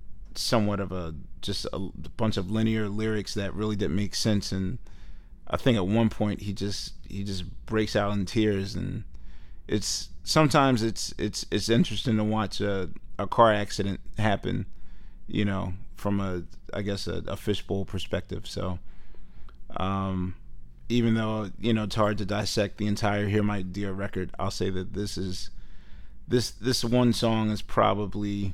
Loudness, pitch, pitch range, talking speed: -28 LUFS, 100 Hz, 95-110 Hz, 165 wpm